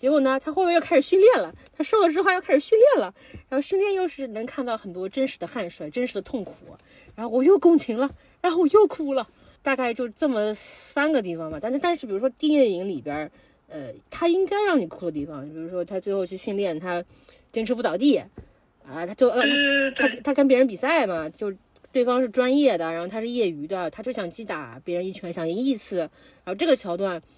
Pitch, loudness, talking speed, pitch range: 255 Hz, -23 LUFS, 325 characters per minute, 185-290 Hz